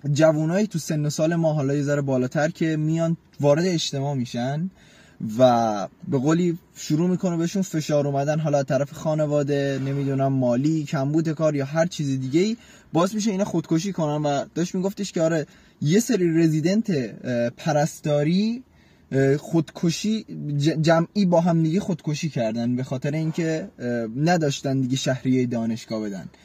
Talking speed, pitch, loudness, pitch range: 145 wpm, 155 Hz, -23 LUFS, 140-170 Hz